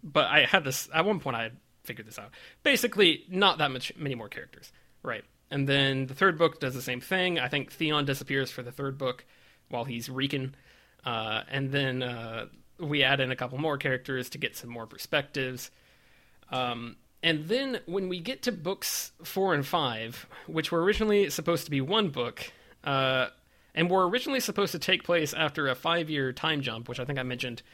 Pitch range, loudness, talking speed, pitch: 130-170 Hz, -28 LUFS, 205 wpm, 140 Hz